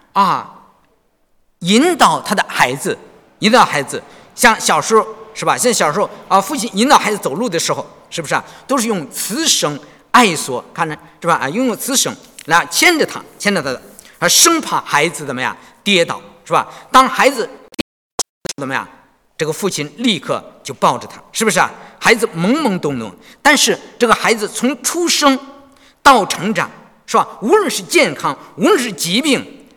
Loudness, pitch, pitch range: -15 LUFS, 240 Hz, 200-275 Hz